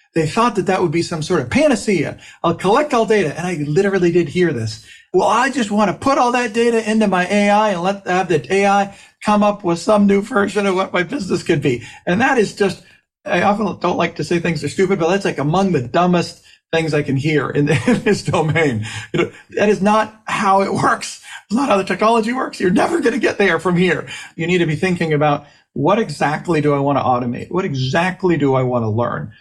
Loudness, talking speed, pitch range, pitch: -17 LUFS, 245 wpm, 160-205 Hz, 185 Hz